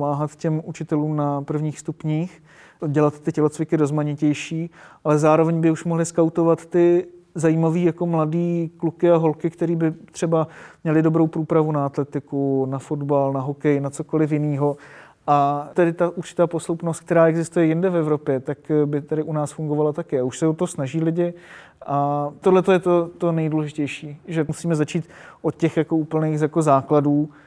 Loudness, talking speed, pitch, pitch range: -21 LUFS, 165 wpm, 160 Hz, 150-165 Hz